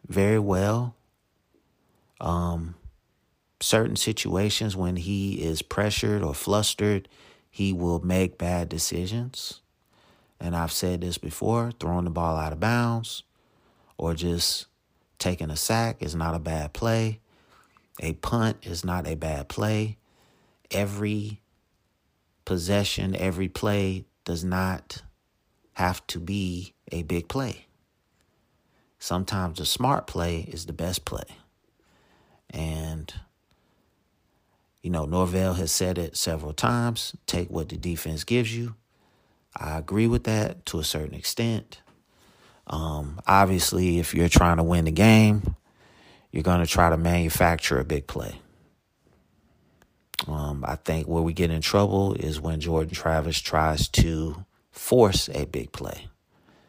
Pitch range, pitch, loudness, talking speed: 80-100 Hz, 90 Hz, -26 LUFS, 130 wpm